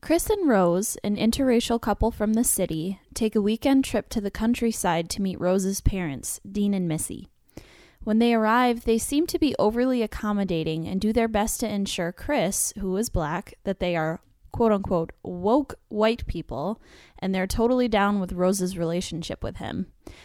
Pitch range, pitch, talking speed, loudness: 185-230 Hz, 205 Hz, 175 wpm, -25 LUFS